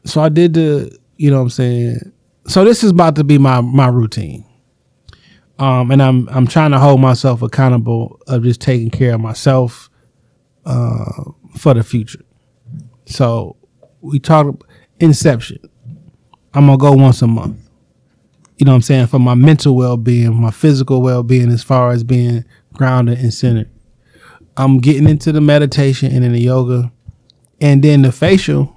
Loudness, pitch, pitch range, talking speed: -12 LUFS, 130 Hz, 120-145 Hz, 165 wpm